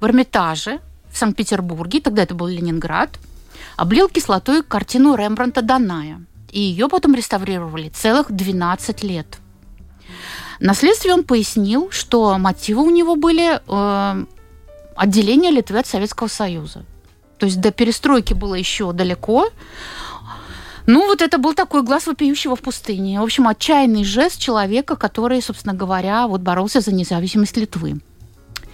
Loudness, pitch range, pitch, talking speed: -17 LUFS, 180-260 Hz, 210 Hz, 130 wpm